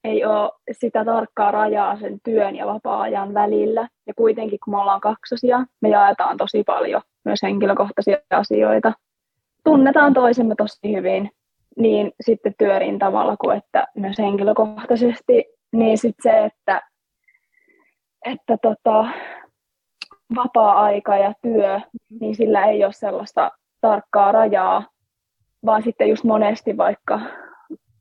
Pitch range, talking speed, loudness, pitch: 205-240 Hz, 120 wpm, -19 LUFS, 220 Hz